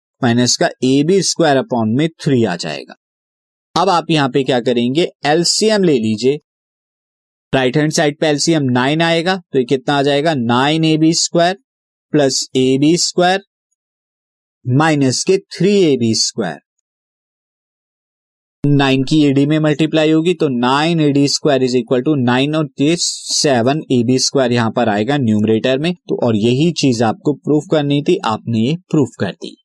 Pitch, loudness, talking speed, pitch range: 140 Hz, -14 LUFS, 165 wpm, 125-160 Hz